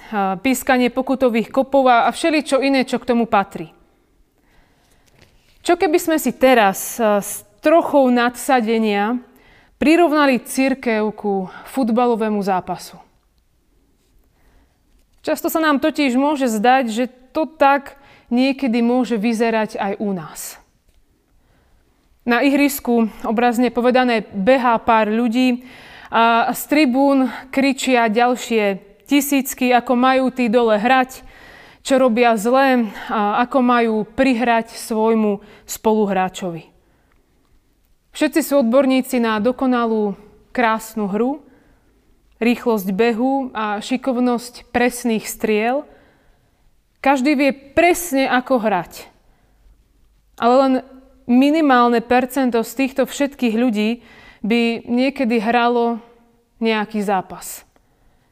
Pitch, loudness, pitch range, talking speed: 245 Hz, -17 LUFS, 225-265 Hz, 100 wpm